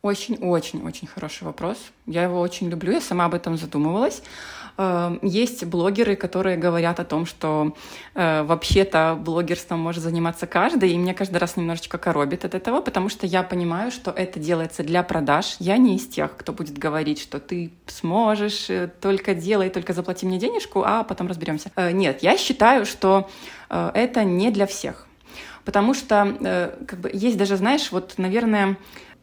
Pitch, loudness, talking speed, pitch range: 185 Hz, -22 LUFS, 160 wpm, 170-200 Hz